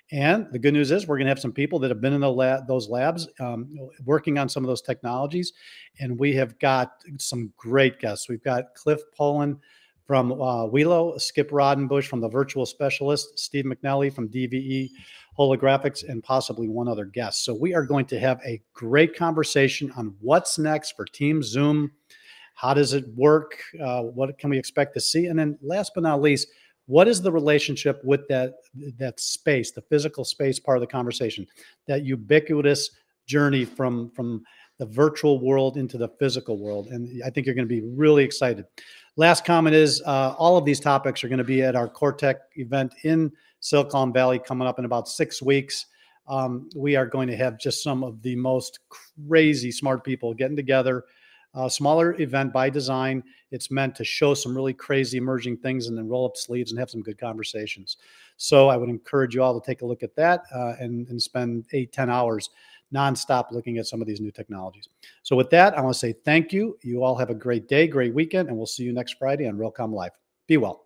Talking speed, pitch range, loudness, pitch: 205 wpm, 125-145 Hz, -23 LUFS, 135 Hz